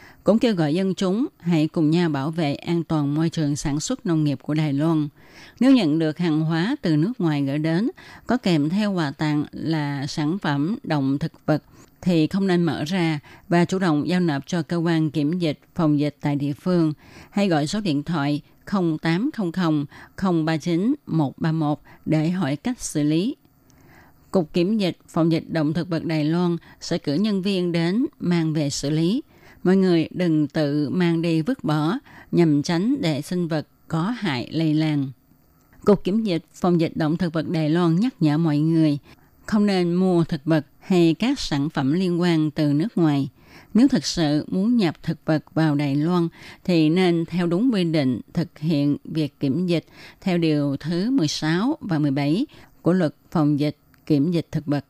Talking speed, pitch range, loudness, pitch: 190 wpm, 150-175 Hz, -22 LUFS, 160 Hz